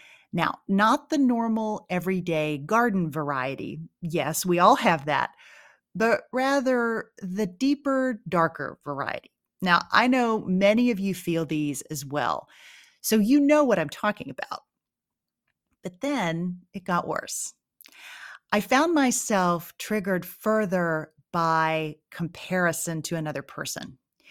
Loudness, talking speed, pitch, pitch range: -25 LUFS, 125 wpm, 185 Hz, 165-230 Hz